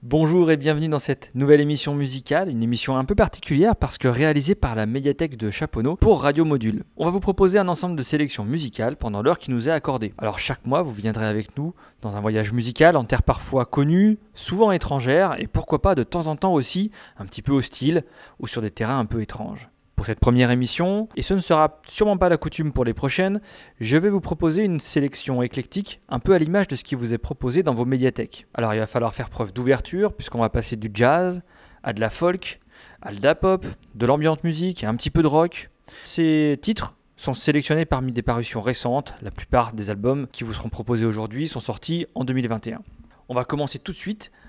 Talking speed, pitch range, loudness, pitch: 225 wpm, 120-165 Hz, -22 LUFS, 140 Hz